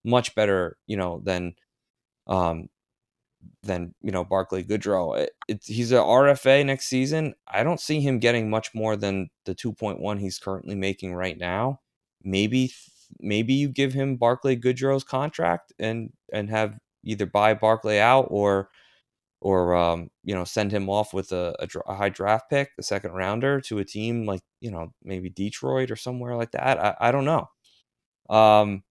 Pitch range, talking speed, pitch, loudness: 95-125 Hz, 170 wpm, 105 Hz, -24 LUFS